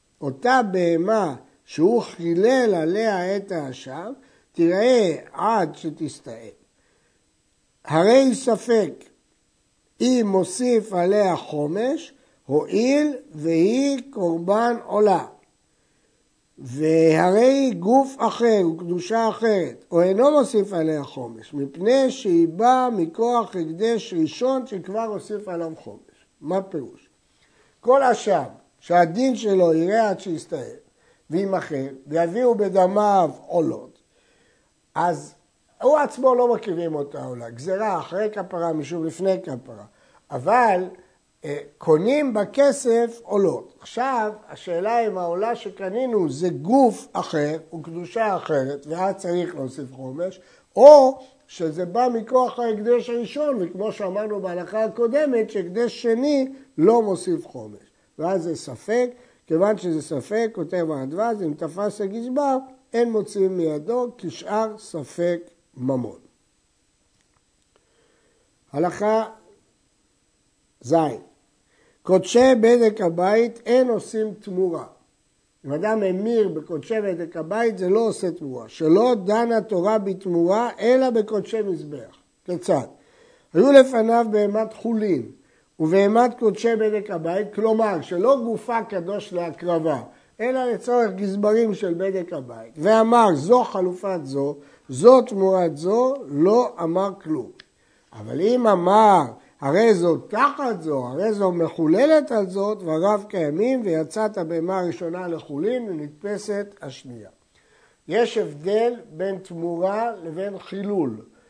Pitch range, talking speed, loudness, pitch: 170-230 Hz, 105 wpm, -21 LUFS, 200 Hz